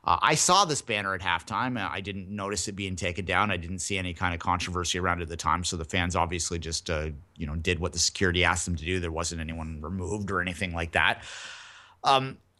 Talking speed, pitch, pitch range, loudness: 245 wpm, 90 Hz, 85-100 Hz, -27 LUFS